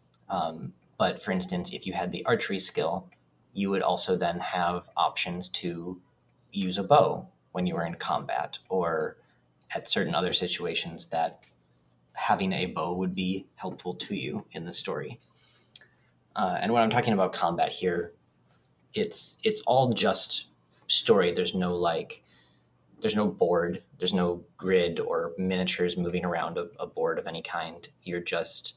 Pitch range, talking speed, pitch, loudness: 85-95 Hz, 160 wpm, 90 Hz, -28 LUFS